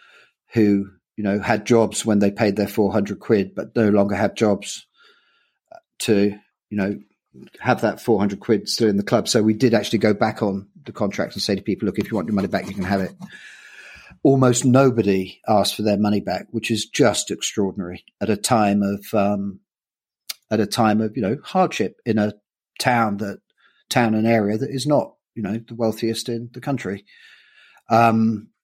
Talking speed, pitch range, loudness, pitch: 195 wpm, 100-115 Hz, -21 LUFS, 110 Hz